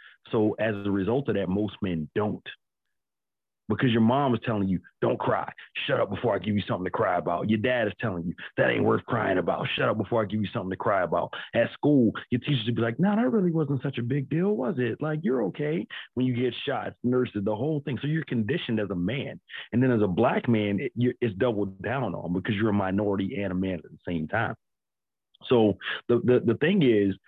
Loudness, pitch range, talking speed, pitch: -27 LUFS, 100-130 Hz, 240 wpm, 115 Hz